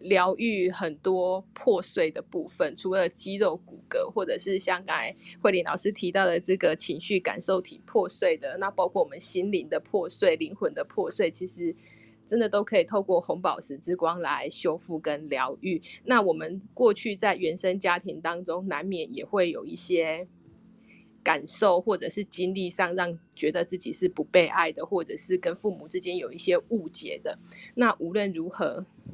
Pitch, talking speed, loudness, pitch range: 190 Hz, 265 characters per minute, -28 LUFS, 175-230 Hz